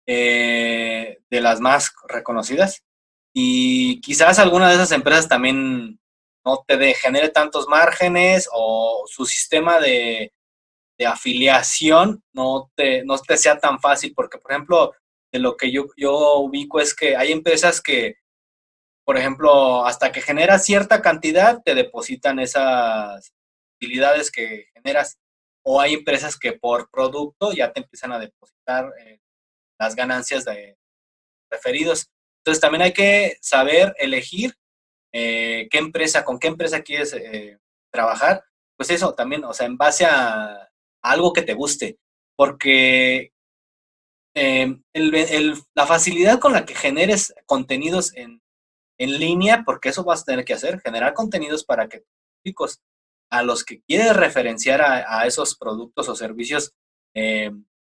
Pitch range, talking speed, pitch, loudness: 115-175 Hz, 145 wpm, 140 Hz, -18 LUFS